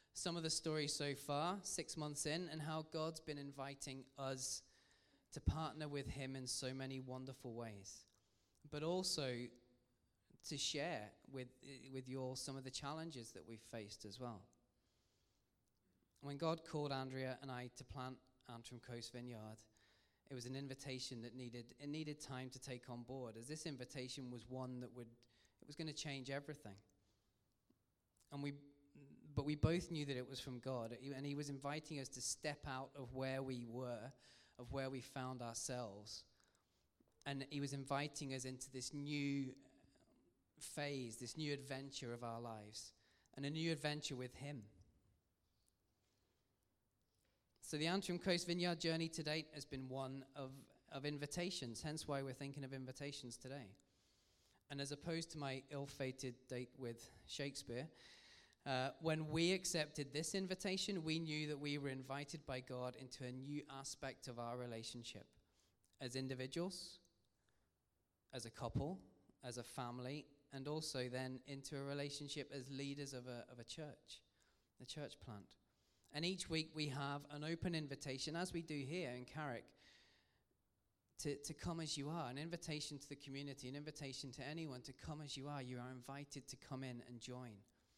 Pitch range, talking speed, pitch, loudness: 120-145 Hz, 170 wpm, 135 Hz, -47 LUFS